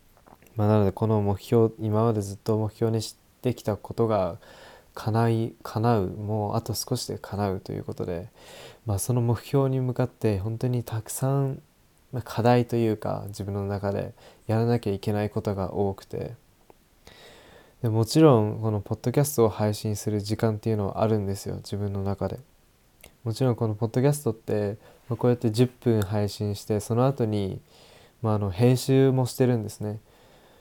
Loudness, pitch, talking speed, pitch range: -26 LUFS, 110 Hz, 335 characters per minute, 105-120 Hz